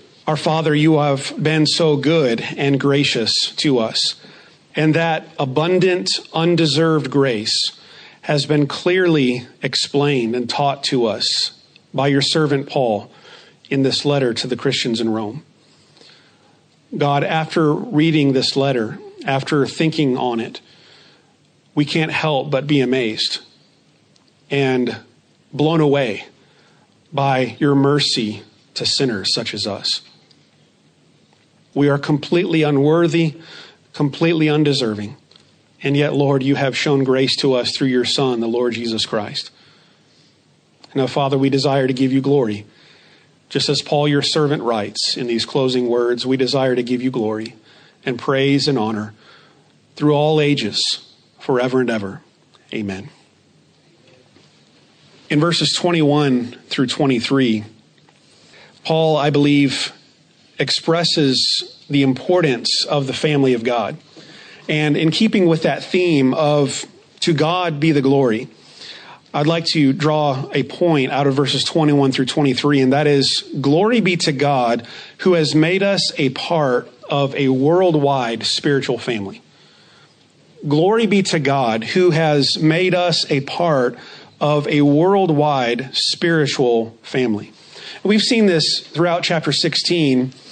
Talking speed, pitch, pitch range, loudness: 130 wpm, 145 Hz, 130-155 Hz, -17 LUFS